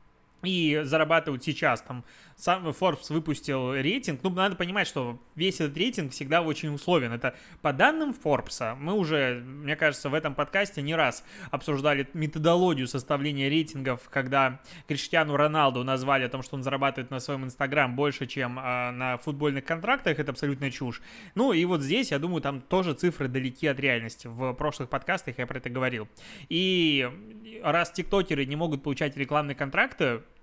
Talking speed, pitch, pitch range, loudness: 160 wpm, 145 Hz, 135-165 Hz, -28 LUFS